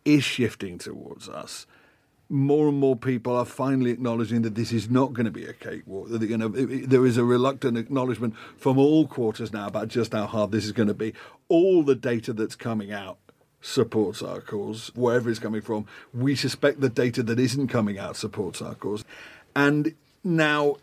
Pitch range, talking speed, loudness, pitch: 110-135 Hz, 185 wpm, -25 LUFS, 125 Hz